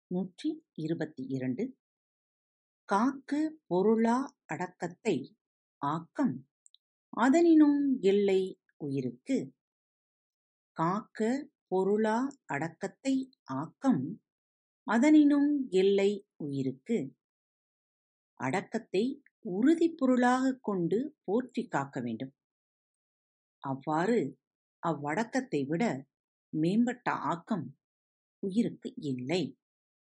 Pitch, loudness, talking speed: 195 Hz, -31 LUFS, 60 wpm